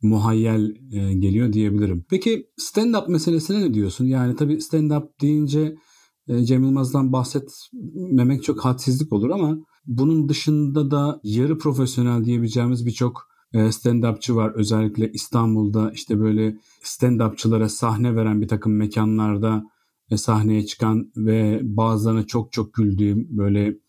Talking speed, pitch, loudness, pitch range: 115 wpm, 120 Hz, -21 LUFS, 110-145 Hz